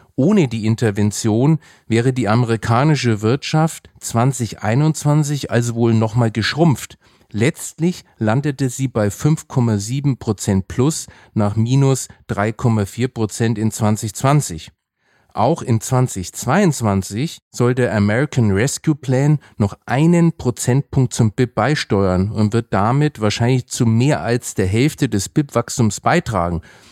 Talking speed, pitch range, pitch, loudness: 110 wpm, 110-140 Hz, 120 Hz, -18 LUFS